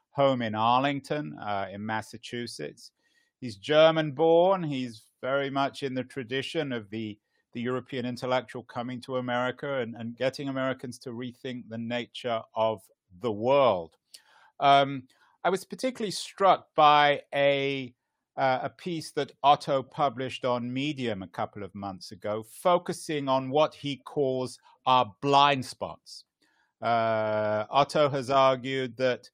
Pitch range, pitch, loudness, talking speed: 120-140 Hz, 130 Hz, -27 LUFS, 135 wpm